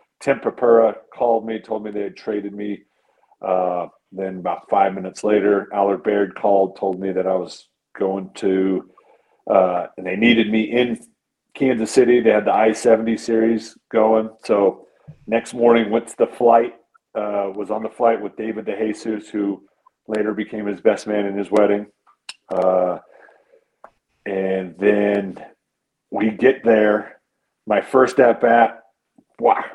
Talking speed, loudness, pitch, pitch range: 150 wpm, -19 LUFS, 105 Hz, 95-115 Hz